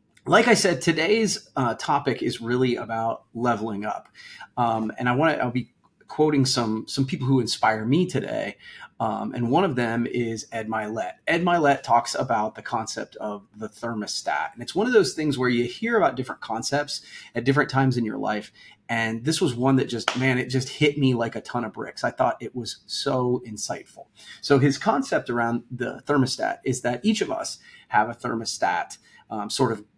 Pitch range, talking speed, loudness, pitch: 115-140 Hz, 200 wpm, -24 LUFS, 125 Hz